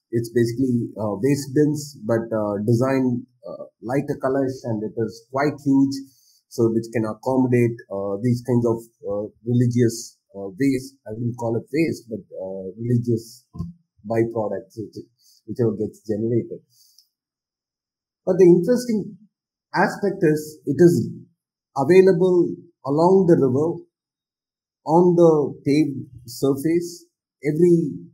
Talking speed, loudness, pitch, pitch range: 120 wpm, -21 LUFS, 130 Hz, 115-155 Hz